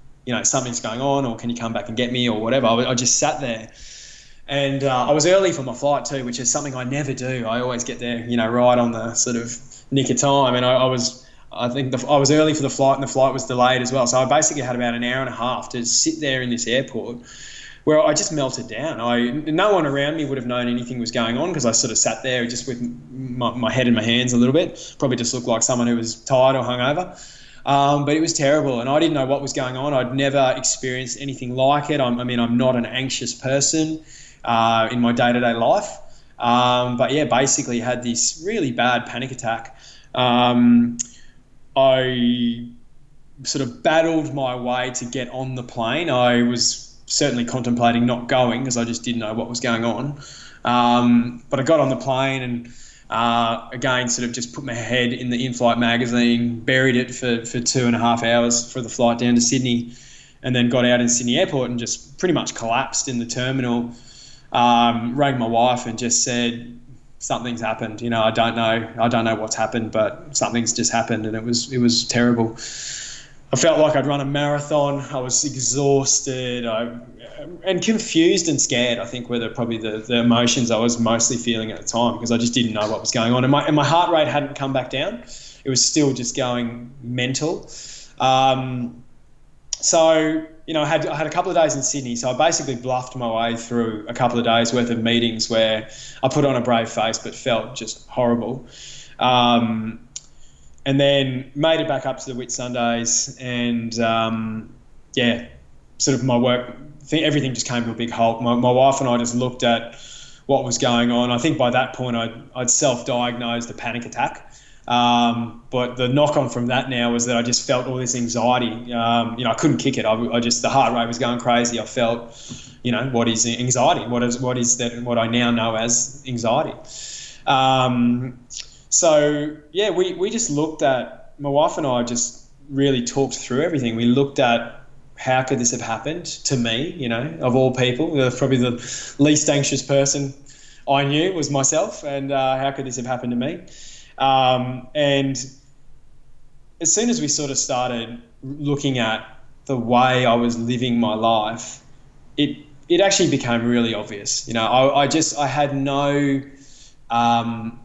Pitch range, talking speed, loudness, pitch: 120-135 Hz, 210 wpm, -20 LUFS, 125 Hz